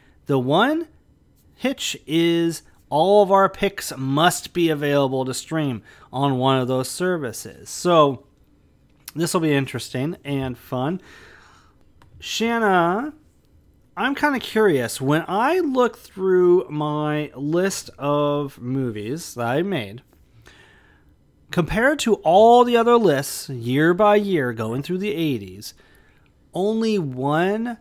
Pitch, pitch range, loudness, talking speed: 160 Hz, 135-200 Hz, -20 LUFS, 120 wpm